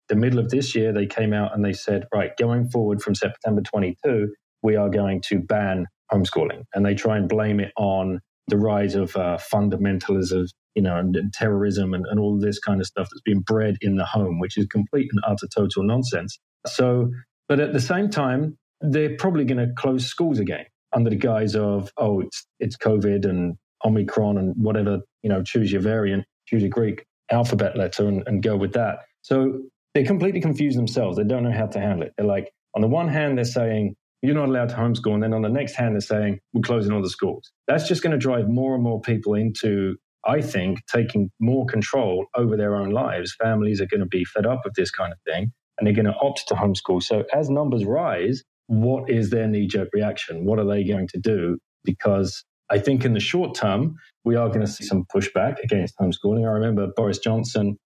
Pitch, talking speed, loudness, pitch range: 105 Hz, 220 wpm, -23 LUFS, 100-120 Hz